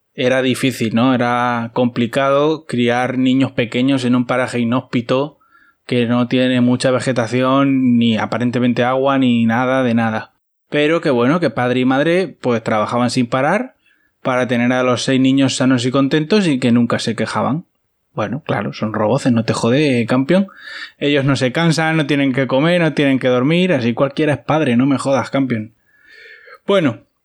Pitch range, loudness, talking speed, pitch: 120-140 Hz, -16 LUFS, 170 wpm, 130 Hz